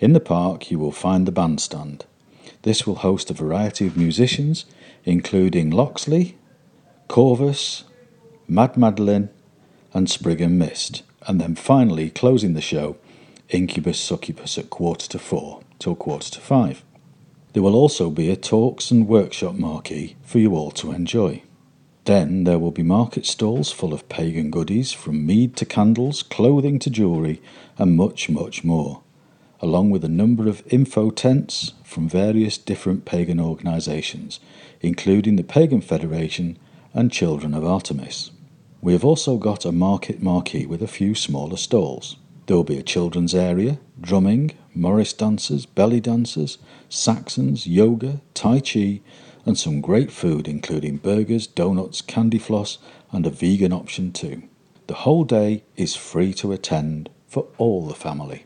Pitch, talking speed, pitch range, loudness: 100 Hz, 150 wpm, 85-120 Hz, -20 LUFS